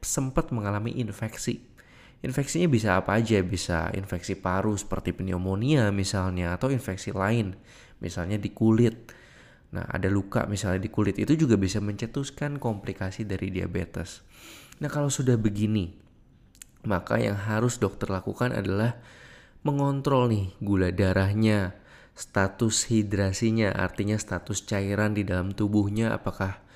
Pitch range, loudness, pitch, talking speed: 95-115 Hz, -27 LUFS, 105 Hz, 125 wpm